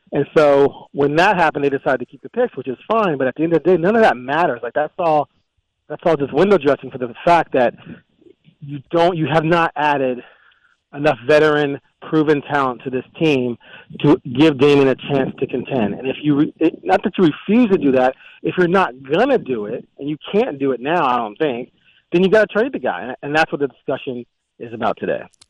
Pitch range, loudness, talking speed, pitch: 135-170 Hz, -17 LUFS, 235 wpm, 150 Hz